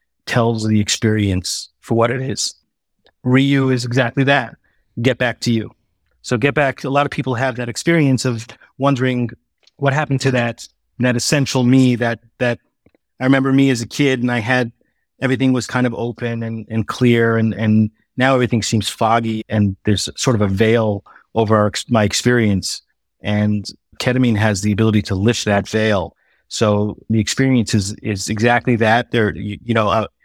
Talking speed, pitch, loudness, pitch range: 180 wpm, 115 Hz, -17 LUFS, 110-130 Hz